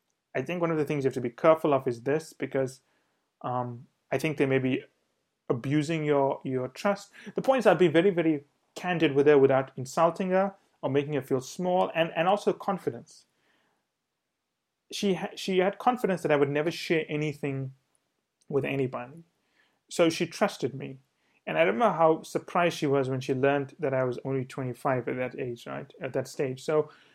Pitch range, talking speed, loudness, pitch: 135-175 Hz, 195 wpm, -28 LUFS, 150 Hz